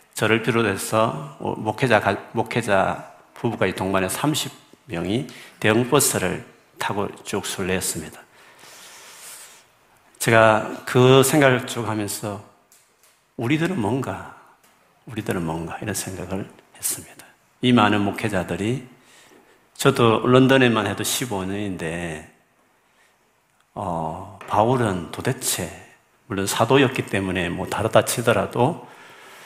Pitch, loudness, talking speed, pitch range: 110 Hz, -21 LUFS, 220 characters per minute, 95-125 Hz